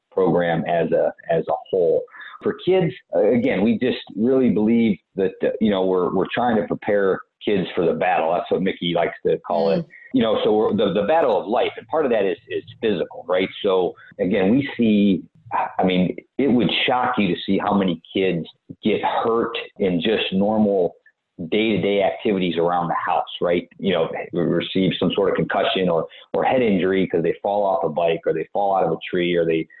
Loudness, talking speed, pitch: -21 LUFS, 205 wpm, 105 Hz